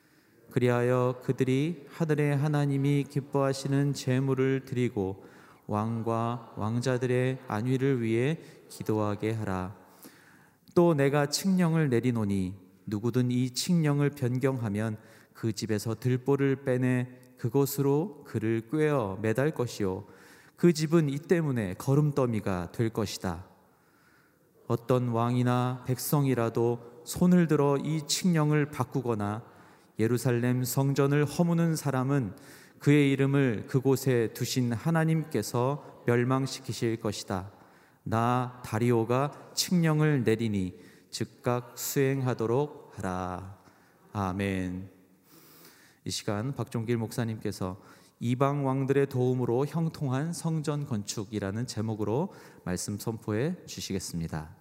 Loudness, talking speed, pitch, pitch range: -29 LUFS, 250 characters per minute, 125 Hz, 110-140 Hz